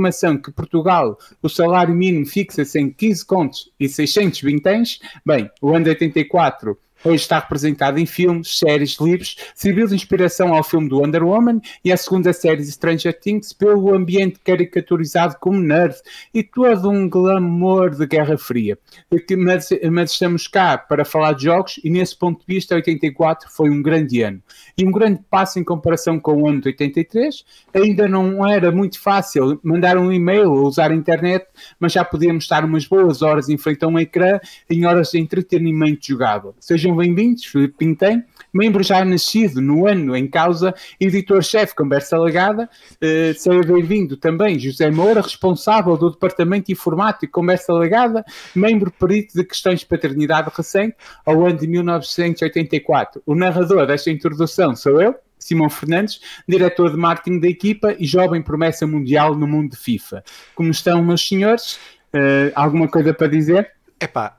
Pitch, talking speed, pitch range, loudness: 175 Hz, 165 wpm, 155-190 Hz, -16 LUFS